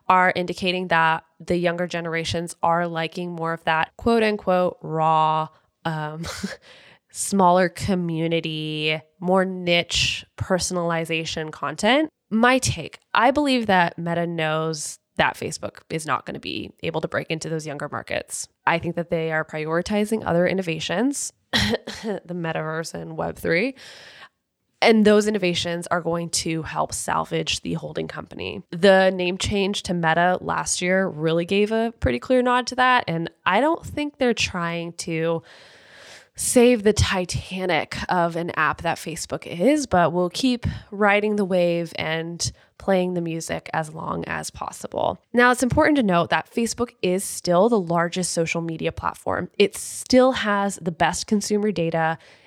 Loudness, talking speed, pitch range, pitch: -22 LUFS, 150 wpm, 165-205 Hz, 175 Hz